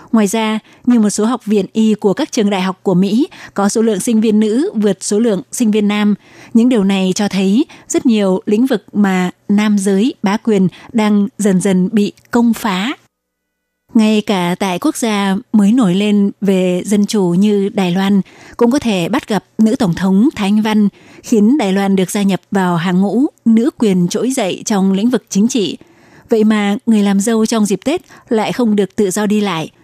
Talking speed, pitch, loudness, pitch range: 210 wpm, 210 Hz, -14 LUFS, 195-225 Hz